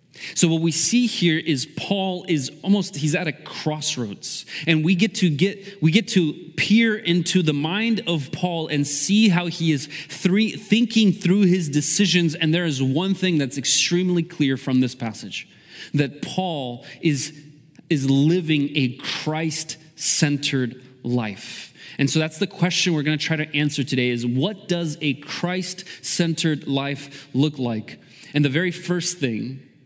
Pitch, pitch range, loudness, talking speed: 160 Hz, 145-180 Hz, -21 LUFS, 165 wpm